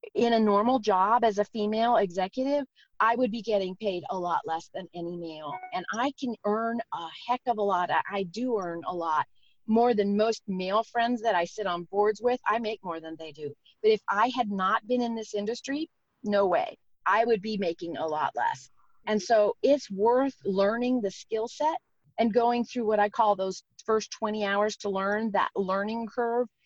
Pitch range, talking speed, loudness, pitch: 195-240 Hz, 205 wpm, -28 LUFS, 220 Hz